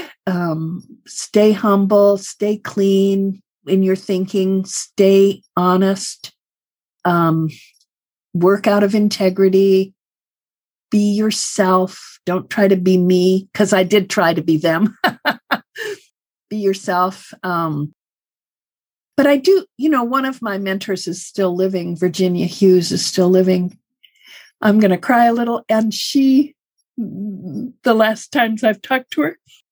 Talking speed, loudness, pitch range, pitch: 125 wpm, -16 LUFS, 185-220 Hz, 195 Hz